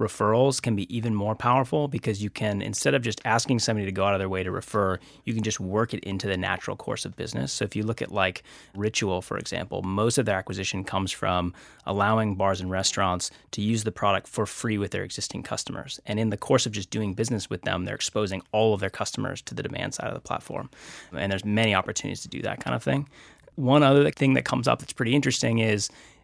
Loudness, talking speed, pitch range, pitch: -26 LUFS, 240 wpm, 95-115 Hz, 105 Hz